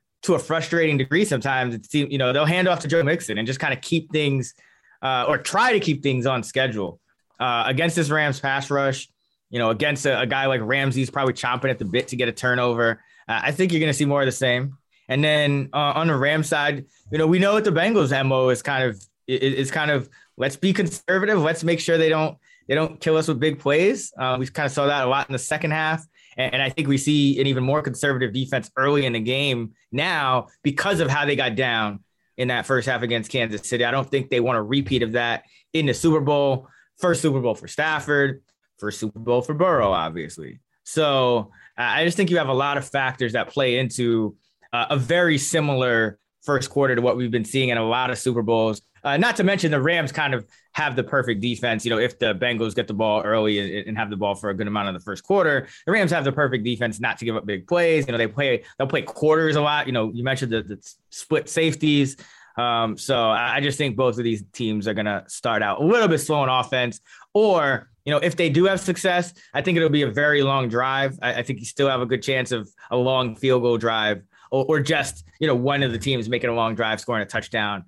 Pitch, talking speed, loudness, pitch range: 135 Hz, 250 wpm, -22 LUFS, 120-150 Hz